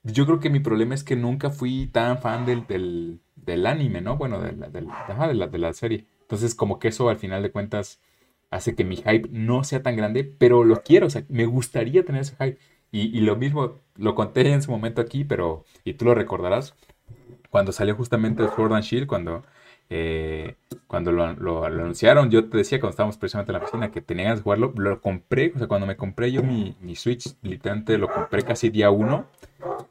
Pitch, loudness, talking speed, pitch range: 115 Hz, -23 LUFS, 225 wpm, 100-125 Hz